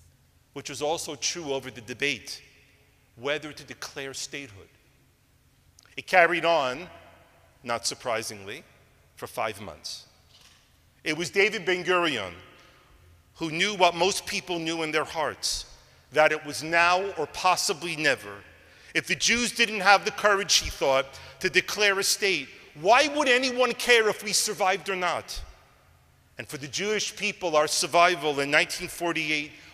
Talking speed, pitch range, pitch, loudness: 145 wpm, 135-190 Hz, 165 Hz, -25 LUFS